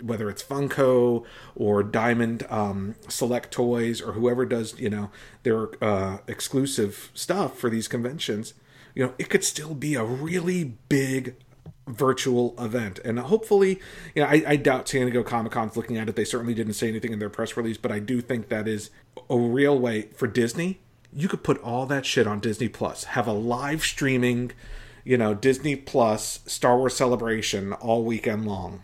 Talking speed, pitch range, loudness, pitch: 185 wpm, 110-135 Hz, -25 LUFS, 120 Hz